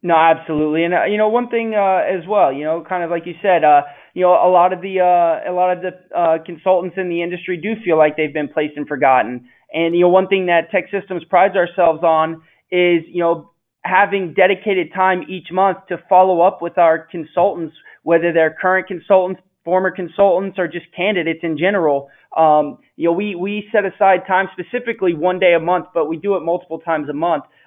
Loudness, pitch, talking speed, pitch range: -16 LUFS, 175 Hz, 215 wpm, 165-185 Hz